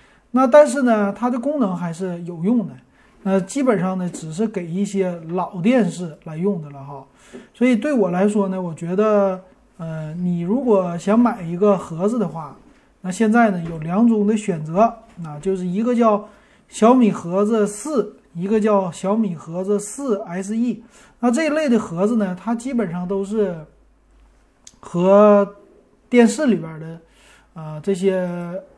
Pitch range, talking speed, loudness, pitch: 180-225 Hz, 225 characters per minute, -19 LUFS, 200 Hz